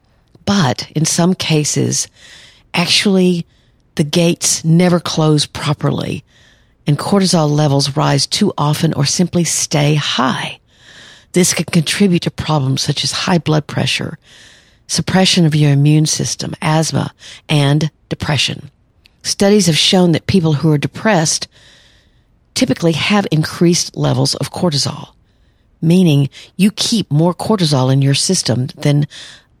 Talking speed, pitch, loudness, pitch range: 125 wpm, 155 Hz, -14 LUFS, 145-175 Hz